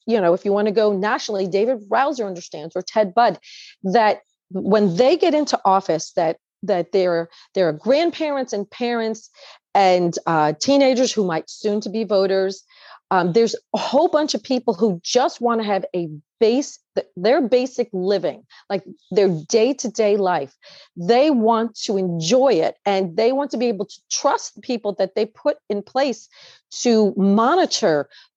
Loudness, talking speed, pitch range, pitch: -20 LUFS, 170 wpm, 190-245 Hz, 215 Hz